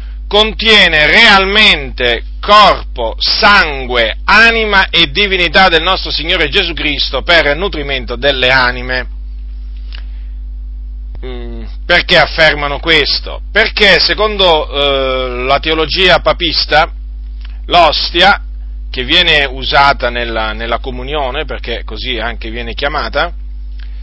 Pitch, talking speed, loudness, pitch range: 135 Hz, 90 wpm, -9 LUFS, 100-170 Hz